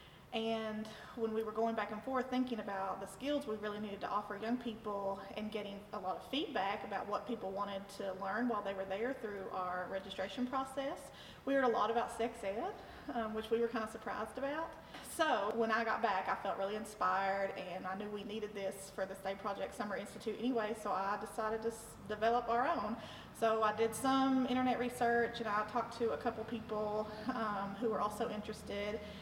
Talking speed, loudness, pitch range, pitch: 210 wpm, -38 LUFS, 205-235 Hz, 215 Hz